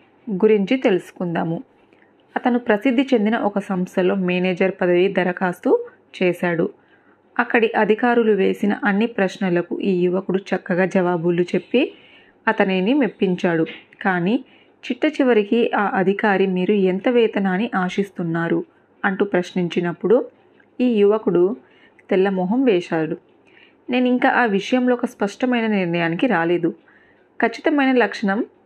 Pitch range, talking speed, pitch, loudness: 185-245 Hz, 105 wpm, 200 Hz, -20 LUFS